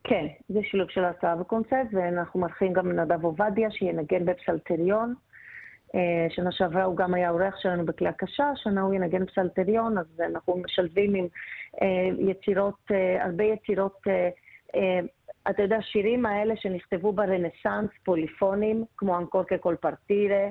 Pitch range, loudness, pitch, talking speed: 180-210 Hz, -27 LUFS, 190 Hz, 125 wpm